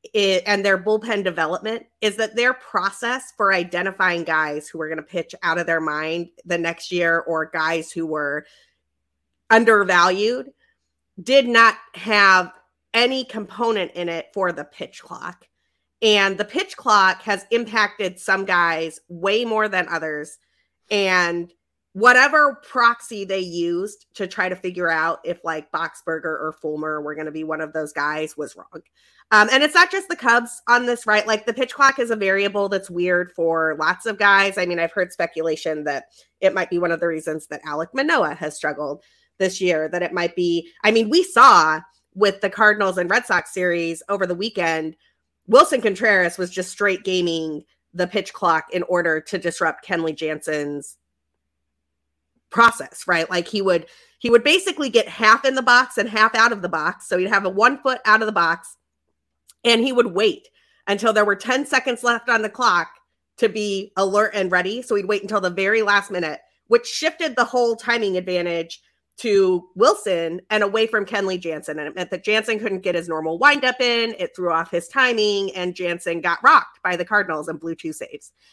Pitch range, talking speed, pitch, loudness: 165-225 Hz, 190 wpm, 190 Hz, -19 LUFS